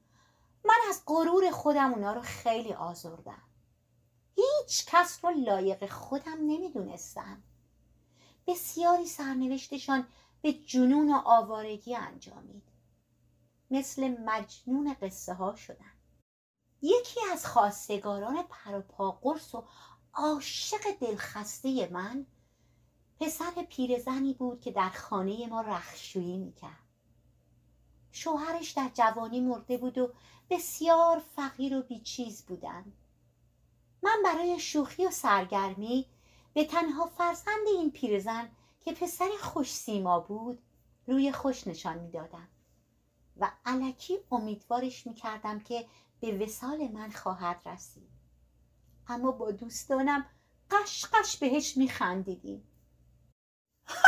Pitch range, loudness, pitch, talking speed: 200-305 Hz, -31 LUFS, 250 Hz, 105 wpm